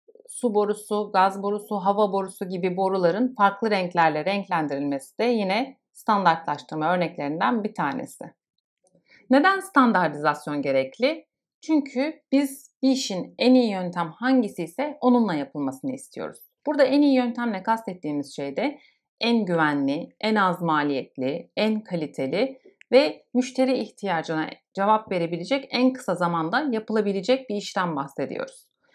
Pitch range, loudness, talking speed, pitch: 170-255 Hz, -24 LUFS, 120 wpm, 210 Hz